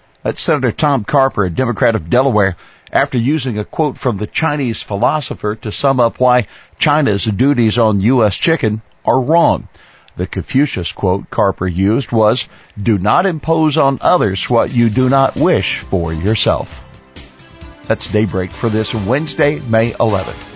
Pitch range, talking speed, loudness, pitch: 105-135 Hz, 150 wpm, -15 LUFS, 115 Hz